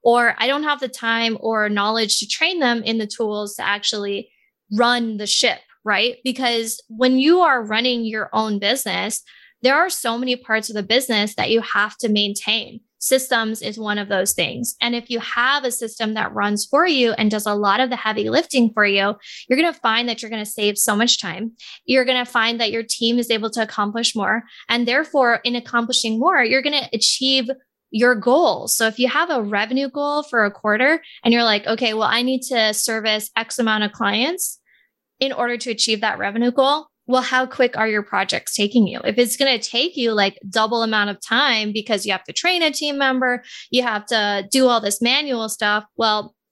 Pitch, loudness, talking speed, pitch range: 230 Hz, -19 LUFS, 210 wpm, 215-255 Hz